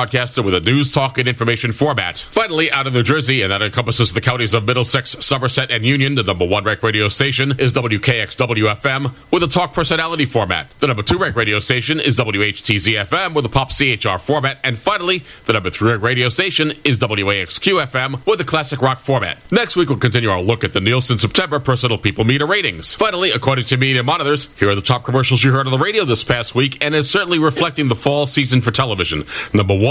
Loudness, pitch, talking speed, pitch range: -16 LUFS, 130 Hz, 215 wpm, 115-140 Hz